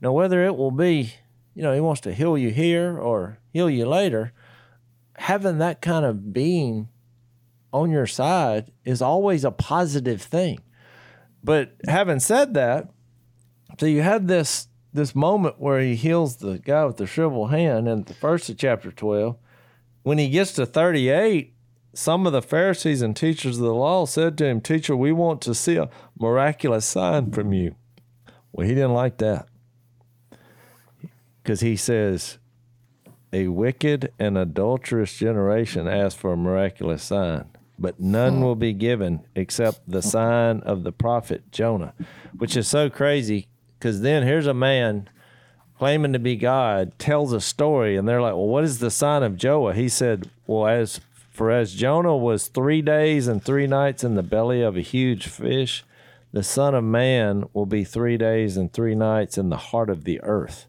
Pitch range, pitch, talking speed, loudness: 110-145 Hz, 120 Hz, 175 wpm, -22 LUFS